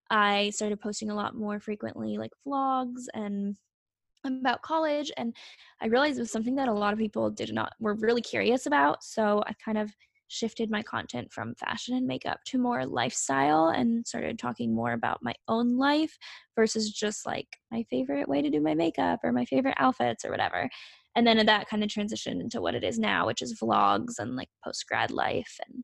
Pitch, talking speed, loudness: 210 Hz, 200 wpm, -29 LUFS